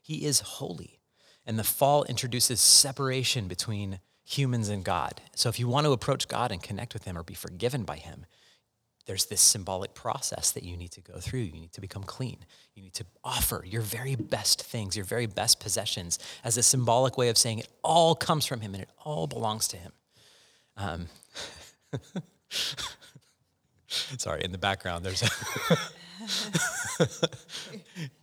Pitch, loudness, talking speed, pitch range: 115 Hz, -27 LUFS, 170 wpm, 100-130 Hz